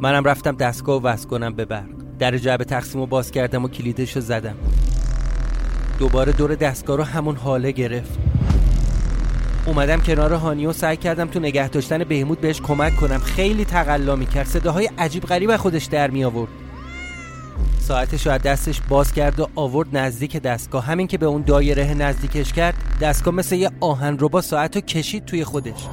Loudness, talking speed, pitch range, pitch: -21 LUFS, 180 wpm, 130-160 Hz, 145 Hz